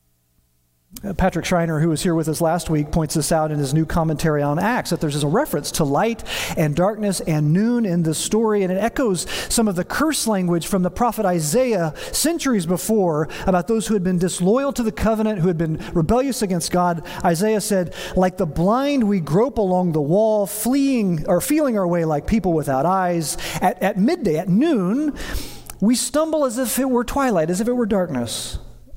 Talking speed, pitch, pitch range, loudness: 200 wpm, 185 Hz, 165-220 Hz, -20 LUFS